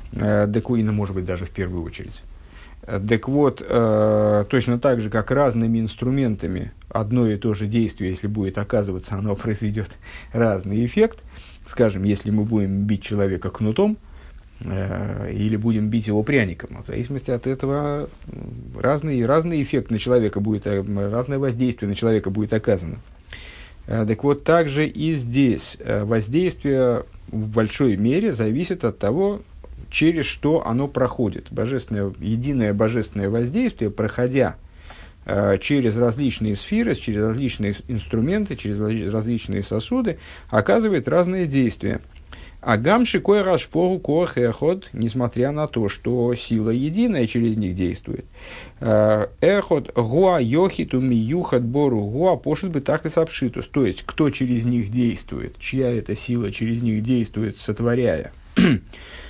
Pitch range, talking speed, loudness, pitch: 105-135 Hz, 135 wpm, -21 LUFS, 115 Hz